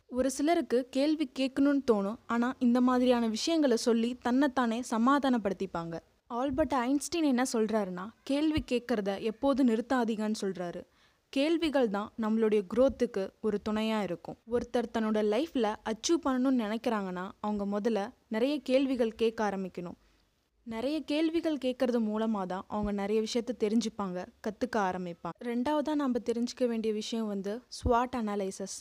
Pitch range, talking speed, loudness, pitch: 215-260 Hz, 125 wpm, -31 LUFS, 235 Hz